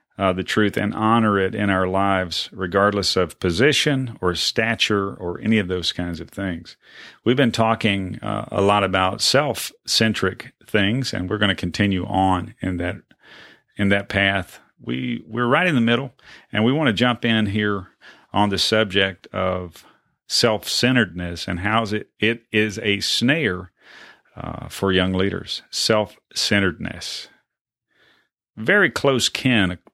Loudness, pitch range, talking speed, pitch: -20 LUFS, 95-110 Hz, 155 wpm, 100 Hz